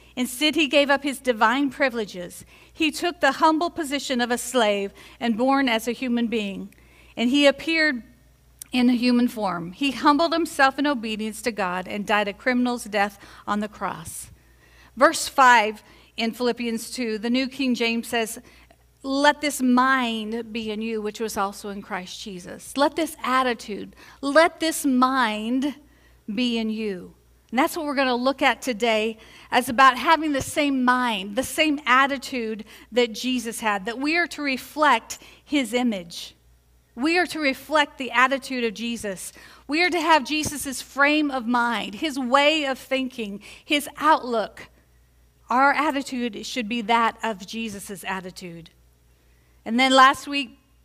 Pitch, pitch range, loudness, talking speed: 245 Hz, 220-280 Hz, -22 LUFS, 160 wpm